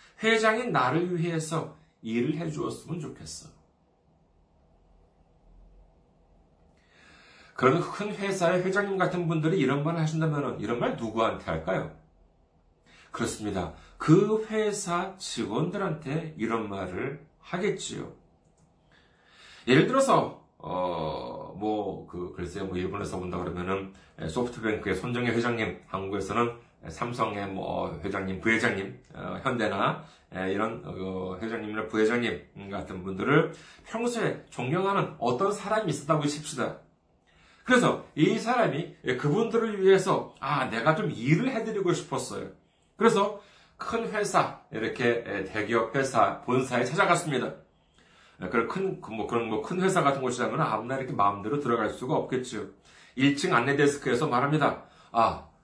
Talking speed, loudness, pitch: 280 characters per minute, -28 LUFS, 120 Hz